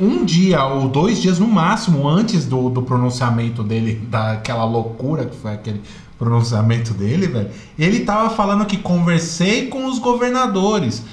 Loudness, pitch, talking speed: -17 LUFS, 145 Hz, 150 wpm